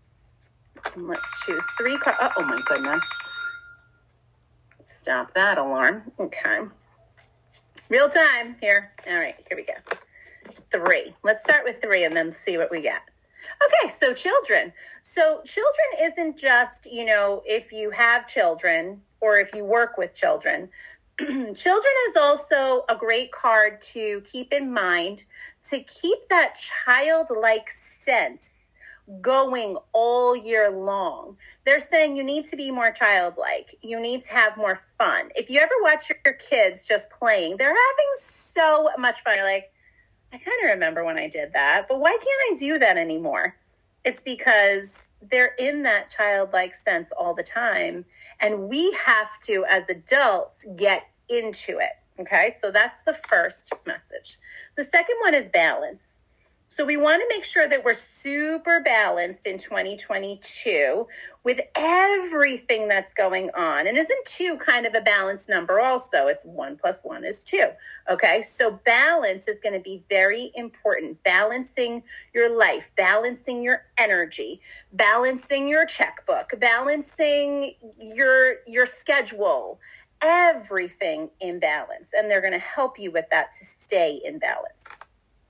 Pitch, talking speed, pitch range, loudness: 250 Hz, 150 wpm, 210-315 Hz, -21 LUFS